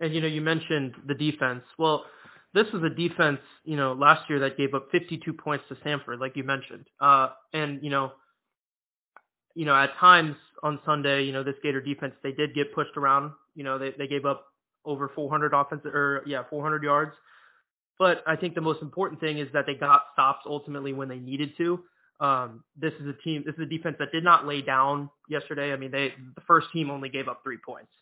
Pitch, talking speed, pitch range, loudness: 145 Hz, 220 wpm, 140-160 Hz, -26 LUFS